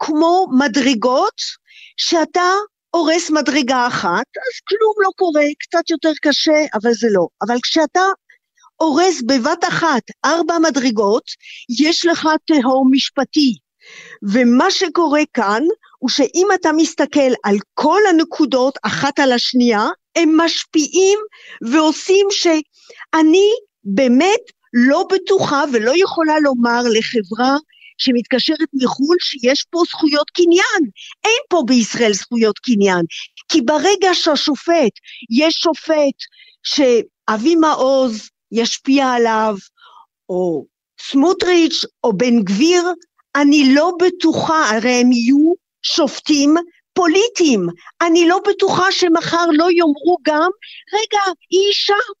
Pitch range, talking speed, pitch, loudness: 255-355 Hz, 110 wpm, 315 Hz, -15 LUFS